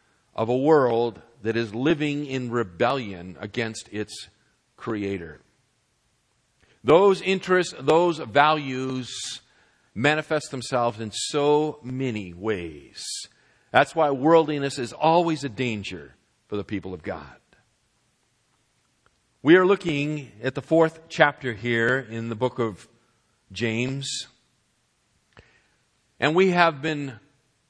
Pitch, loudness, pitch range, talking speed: 130 Hz, -24 LUFS, 115-150 Hz, 110 wpm